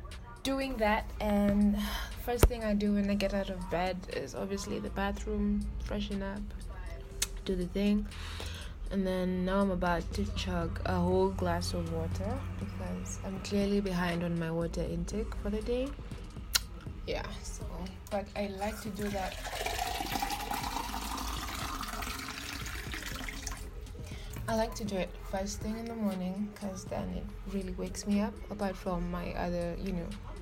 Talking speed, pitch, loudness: 150 wpm, 190 Hz, -34 LUFS